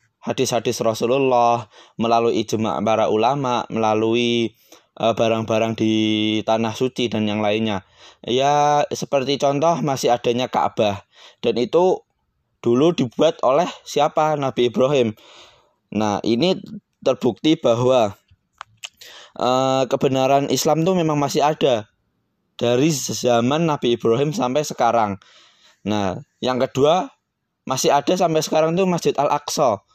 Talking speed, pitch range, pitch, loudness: 110 wpm, 115-145 Hz, 125 Hz, -19 LUFS